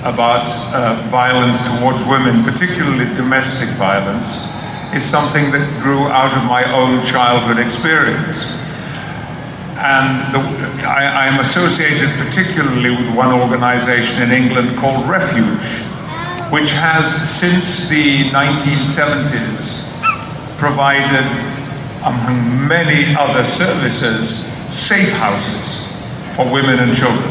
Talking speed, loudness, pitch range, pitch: 105 wpm, -14 LUFS, 125-150 Hz, 135 Hz